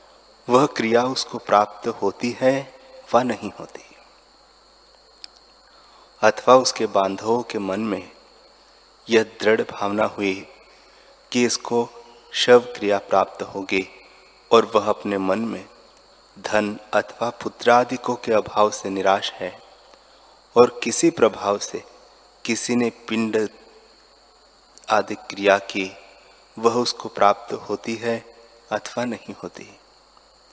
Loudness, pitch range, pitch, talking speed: -21 LUFS, 100-120 Hz, 110 Hz, 110 wpm